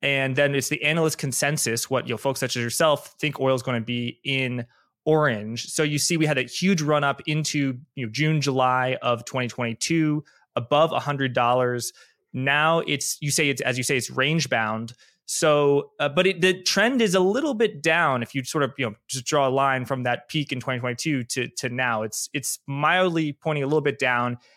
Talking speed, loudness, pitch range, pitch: 215 wpm, -23 LUFS, 125-155 Hz, 140 Hz